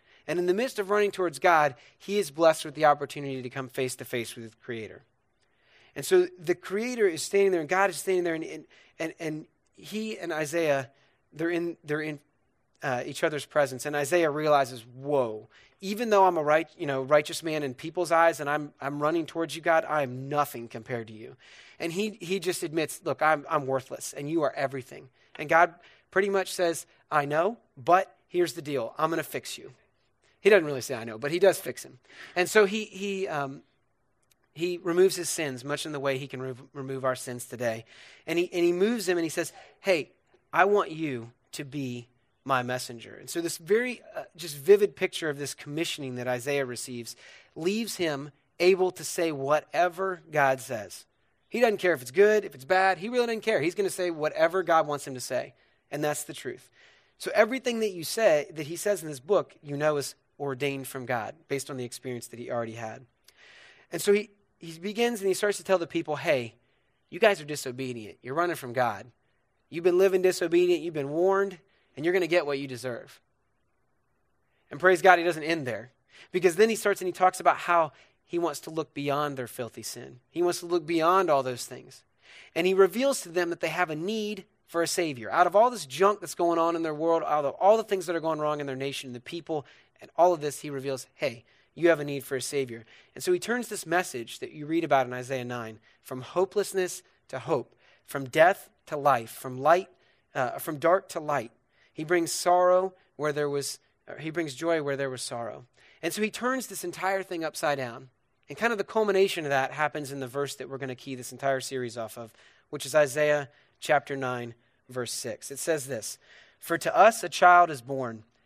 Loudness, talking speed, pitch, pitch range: -27 LUFS, 220 wpm, 155 Hz, 135-180 Hz